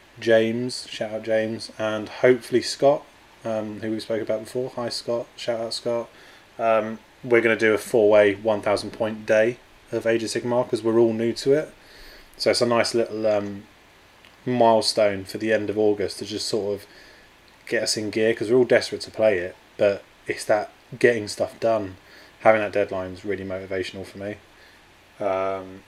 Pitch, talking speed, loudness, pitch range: 110 Hz, 185 wpm, -23 LUFS, 100-115 Hz